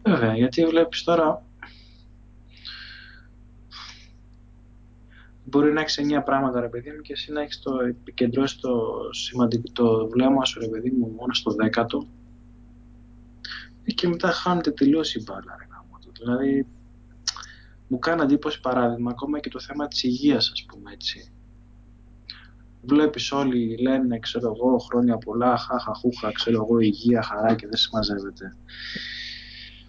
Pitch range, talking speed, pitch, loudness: 115-130 Hz, 135 wpm, 120 Hz, -24 LUFS